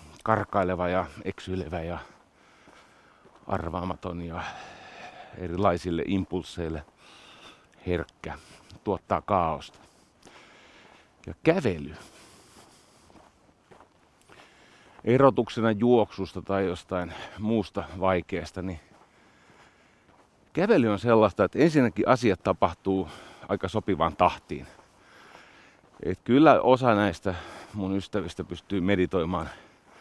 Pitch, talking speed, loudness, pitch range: 95 Hz, 75 wpm, -26 LUFS, 90-100 Hz